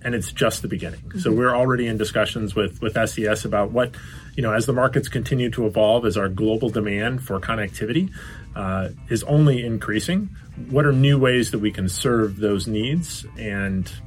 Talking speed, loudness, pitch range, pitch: 190 wpm, -22 LUFS, 105-125 Hz, 110 Hz